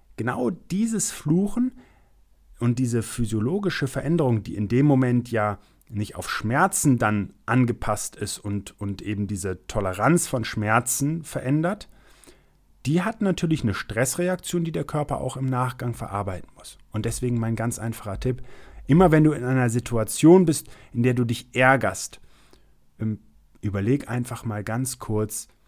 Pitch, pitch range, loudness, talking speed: 125 Hz, 110-145 Hz, -24 LUFS, 145 wpm